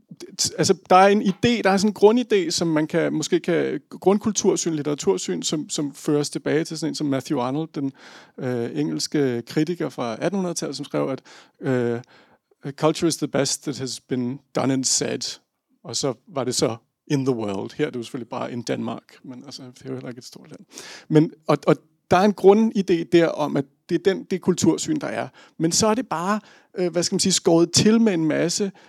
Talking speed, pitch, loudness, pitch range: 220 wpm, 160 Hz, -22 LUFS, 135-190 Hz